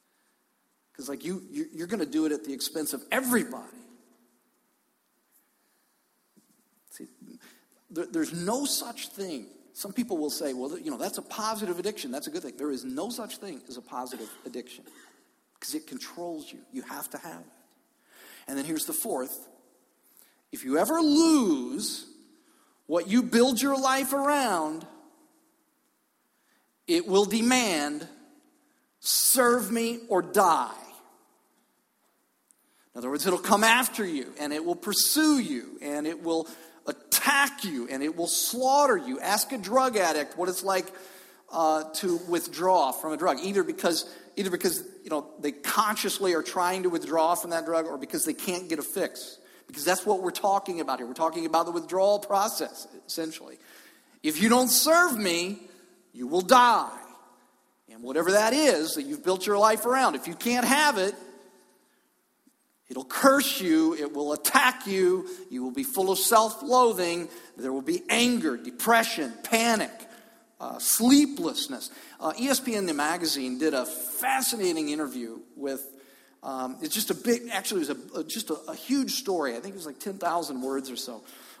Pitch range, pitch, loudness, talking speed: 165-270 Hz, 205 Hz, -26 LUFS, 160 wpm